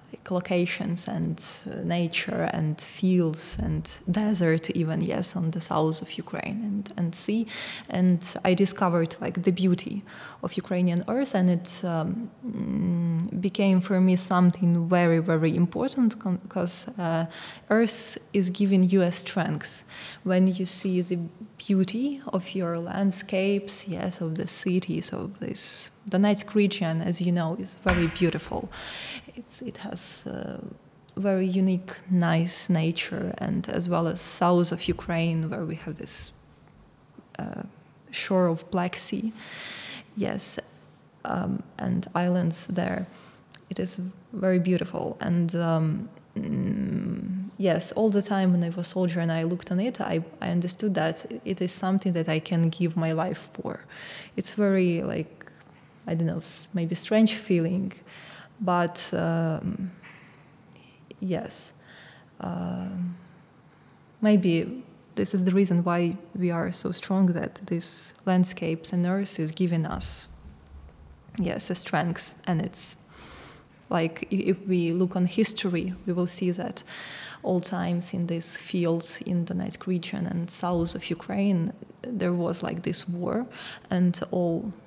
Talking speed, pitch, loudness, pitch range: 140 wpm, 180 Hz, -27 LUFS, 170-195 Hz